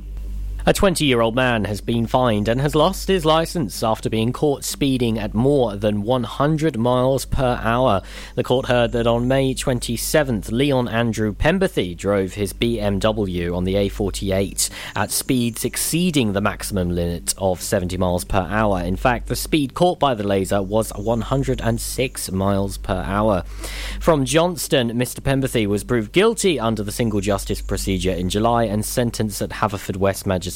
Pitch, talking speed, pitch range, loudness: 110 Hz, 165 wpm, 100-130 Hz, -20 LUFS